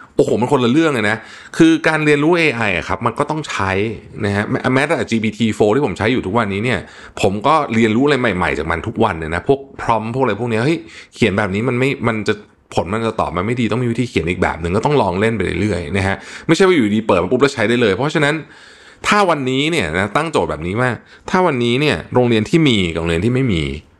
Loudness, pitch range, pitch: -16 LUFS, 100-140 Hz, 115 Hz